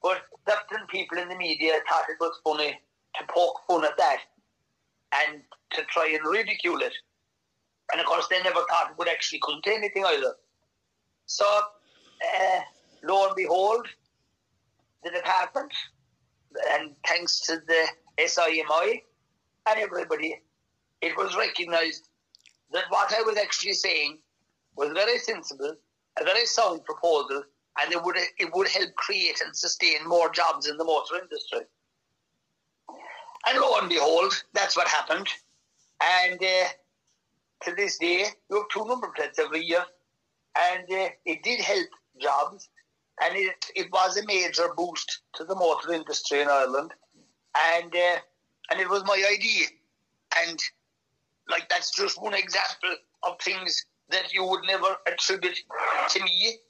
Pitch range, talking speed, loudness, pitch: 165-230 Hz, 145 wpm, -26 LUFS, 185 Hz